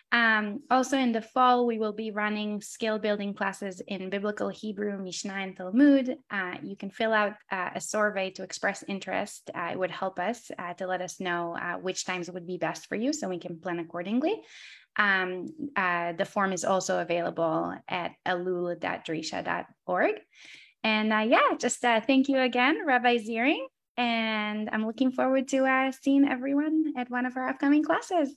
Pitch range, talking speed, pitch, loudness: 185-255 Hz, 180 wpm, 215 Hz, -28 LUFS